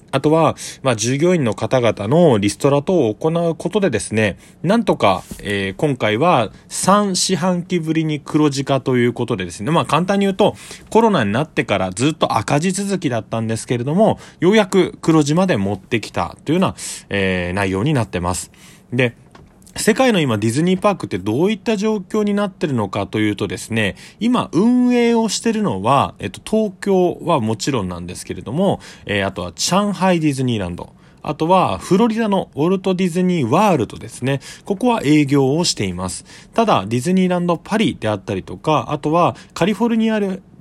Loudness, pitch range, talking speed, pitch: -18 LUFS, 115-190 Hz, 385 characters per minute, 155 Hz